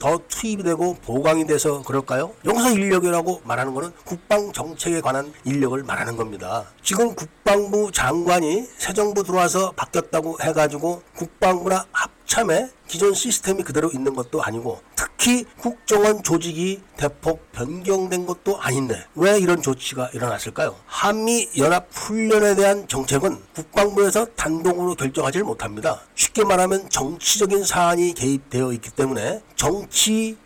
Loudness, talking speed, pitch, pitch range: -21 LUFS, 340 characters per minute, 175 Hz, 145-200 Hz